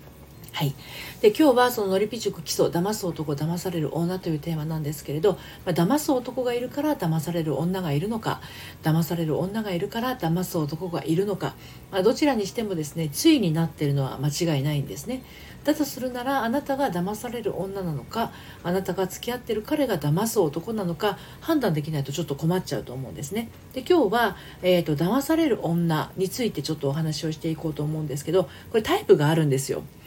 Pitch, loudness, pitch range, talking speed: 180 Hz, -25 LUFS, 155-230 Hz, 425 characters per minute